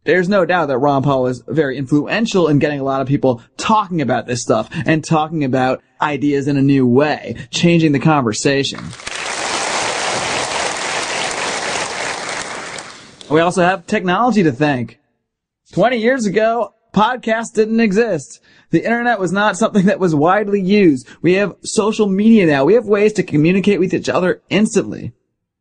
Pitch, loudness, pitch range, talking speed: 170 Hz, -16 LUFS, 140-210 Hz, 150 wpm